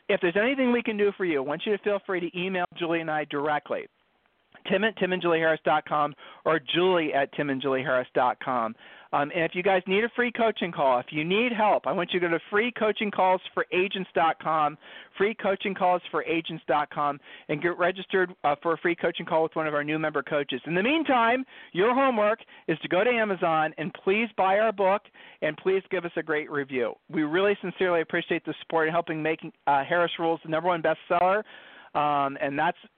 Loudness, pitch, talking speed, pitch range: -26 LUFS, 175 Hz, 230 wpm, 155-195 Hz